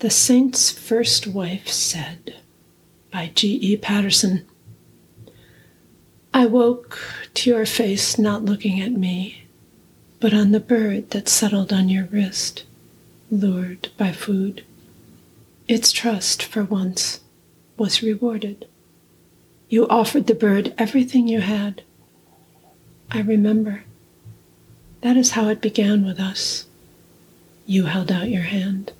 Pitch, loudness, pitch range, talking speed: 210 Hz, -19 LUFS, 190-225 Hz, 115 wpm